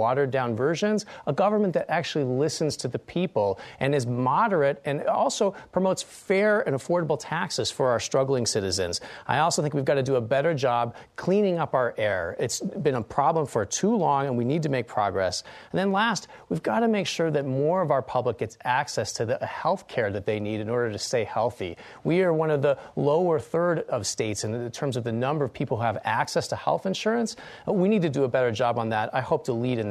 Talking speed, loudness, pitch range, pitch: 235 wpm, -26 LUFS, 125-175 Hz, 145 Hz